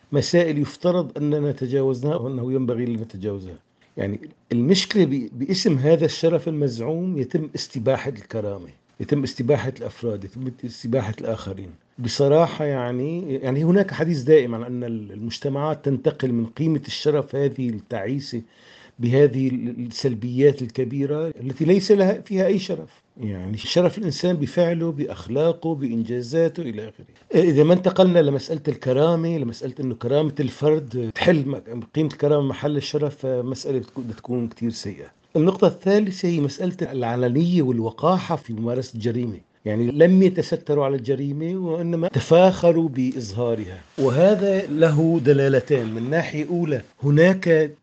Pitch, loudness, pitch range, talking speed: 140 Hz, -21 LUFS, 120-165 Hz, 120 wpm